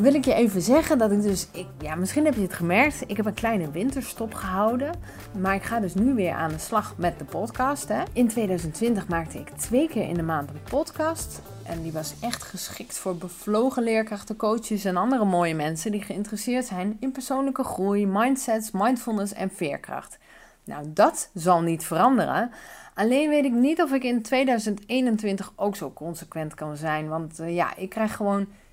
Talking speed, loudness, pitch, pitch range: 190 wpm, -25 LUFS, 210 Hz, 180-250 Hz